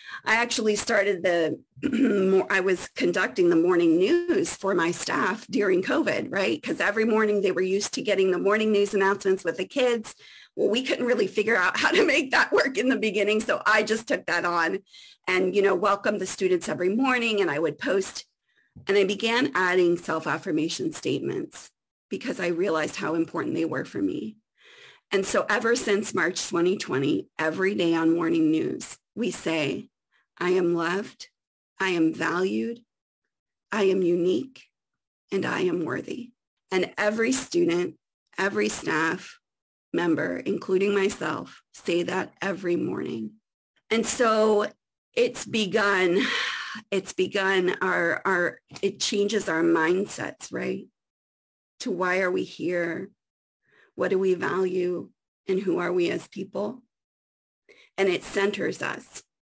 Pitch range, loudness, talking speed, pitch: 180-225 Hz, -25 LUFS, 150 wpm, 195 Hz